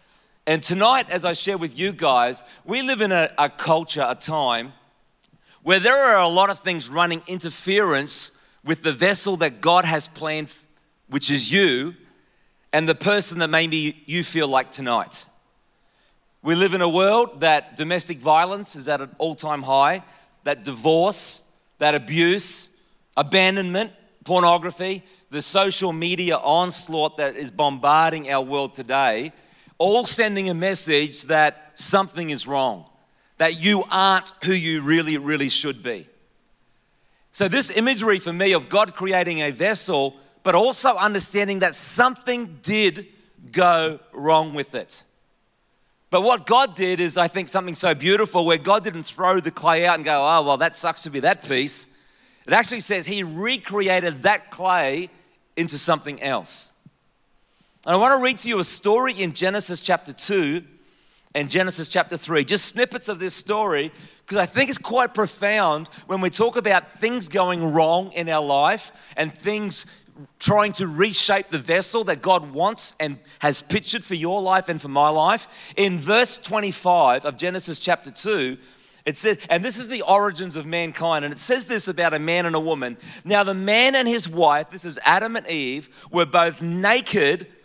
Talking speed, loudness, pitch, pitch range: 170 wpm, -20 LUFS, 175 Hz, 155-200 Hz